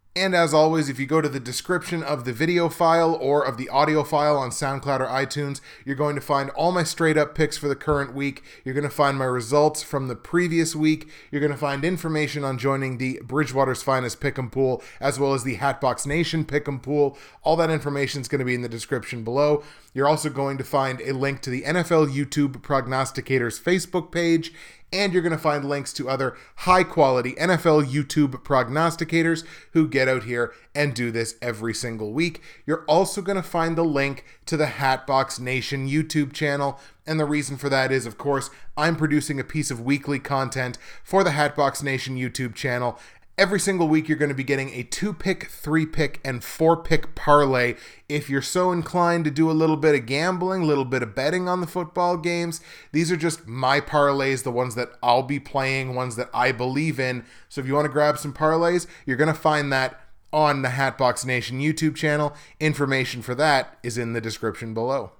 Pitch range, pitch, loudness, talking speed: 130-155 Hz, 145 Hz, -23 LUFS, 205 wpm